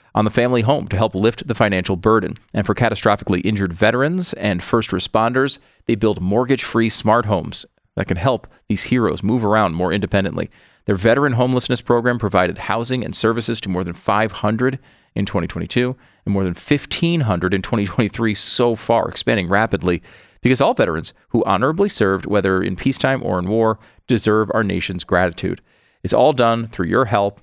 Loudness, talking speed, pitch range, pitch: -18 LUFS, 175 wpm, 100-120 Hz, 110 Hz